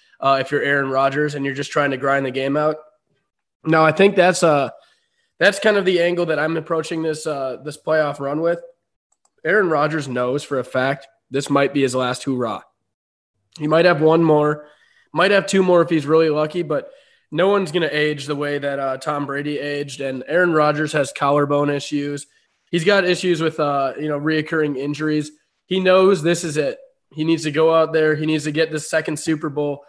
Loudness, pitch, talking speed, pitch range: -19 LUFS, 155 Hz, 210 wpm, 145-165 Hz